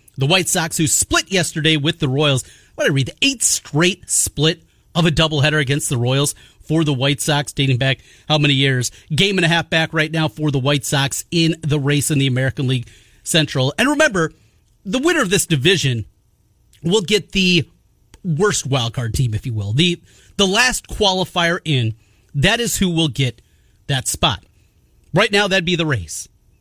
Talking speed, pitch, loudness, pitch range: 190 wpm, 150 Hz, -17 LUFS, 125-170 Hz